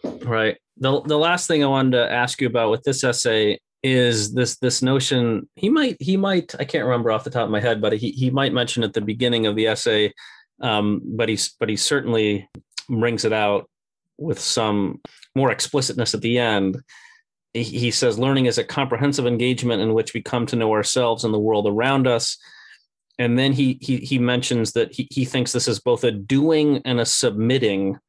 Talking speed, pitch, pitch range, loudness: 205 wpm, 120 Hz, 110-135 Hz, -20 LUFS